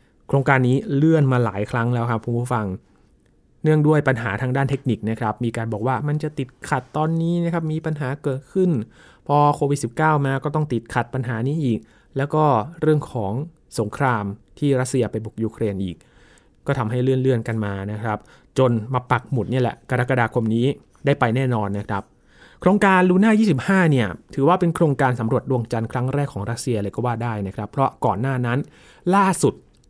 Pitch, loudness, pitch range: 130 Hz, -21 LUFS, 115-145 Hz